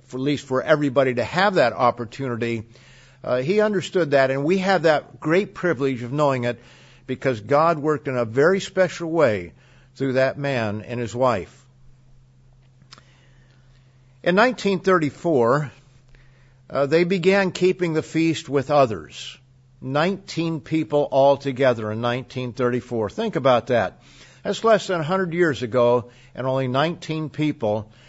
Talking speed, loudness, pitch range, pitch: 140 wpm, -21 LUFS, 125-160 Hz, 135 Hz